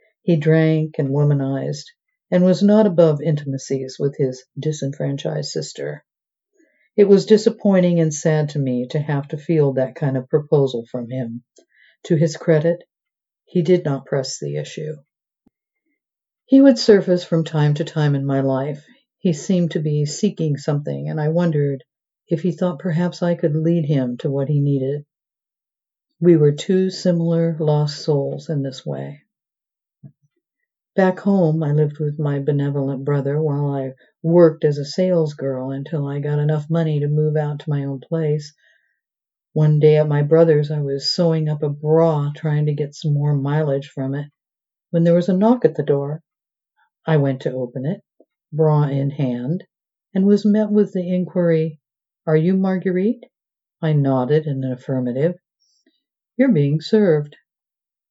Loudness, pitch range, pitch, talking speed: -19 LUFS, 140-175 Hz, 155 Hz, 165 wpm